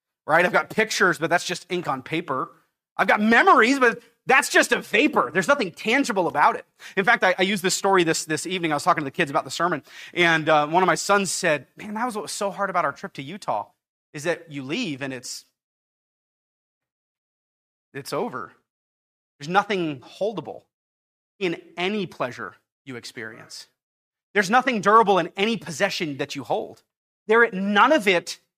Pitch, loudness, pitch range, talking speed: 180 Hz, -22 LUFS, 155-205 Hz, 190 wpm